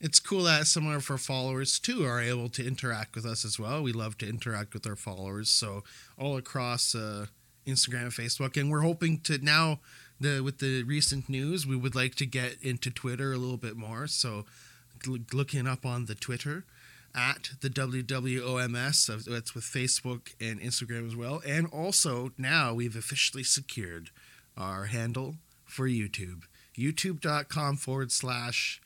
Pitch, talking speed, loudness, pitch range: 130 Hz, 170 wpm, -30 LUFS, 120-140 Hz